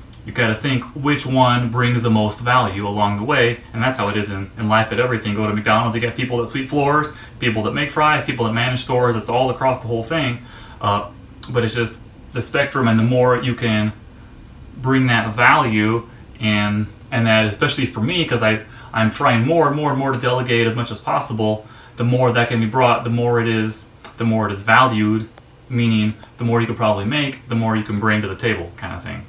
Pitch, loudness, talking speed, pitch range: 115 Hz, -18 LUFS, 230 wpm, 110-125 Hz